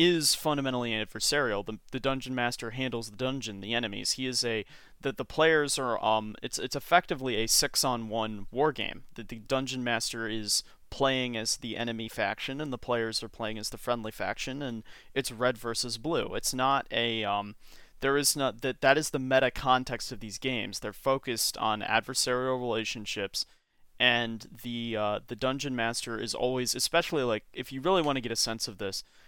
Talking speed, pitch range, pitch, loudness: 190 wpm, 110-135 Hz, 120 Hz, -29 LUFS